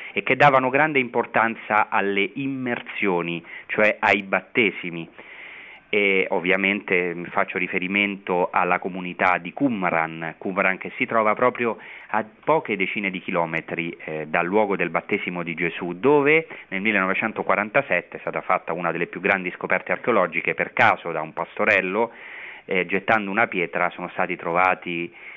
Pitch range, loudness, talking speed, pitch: 85-110 Hz, -22 LUFS, 140 wpm, 95 Hz